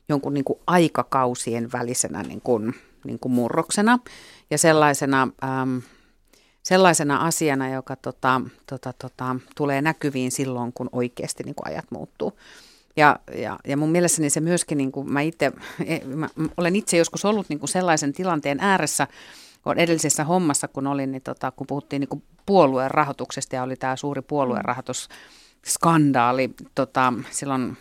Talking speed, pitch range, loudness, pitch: 145 wpm, 130-160 Hz, -23 LUFS, 140 Hz